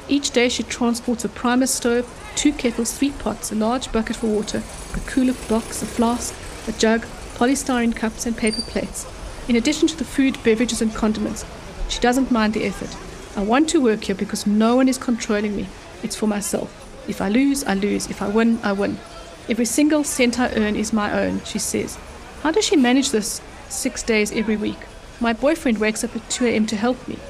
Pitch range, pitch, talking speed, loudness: 220-255 Hz, 235 Hz, 205 wpm, -21 LUFS